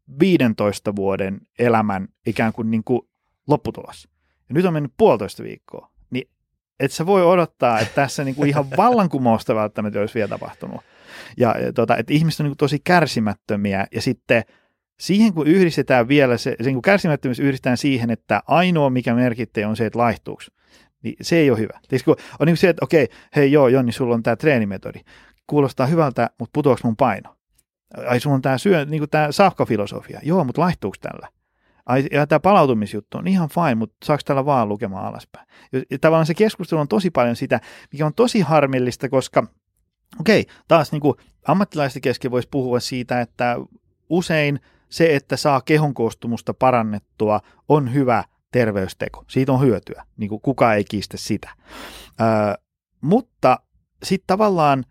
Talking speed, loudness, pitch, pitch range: 160 wpm, -19 LUFS, 130 Hz, 115-155 Hz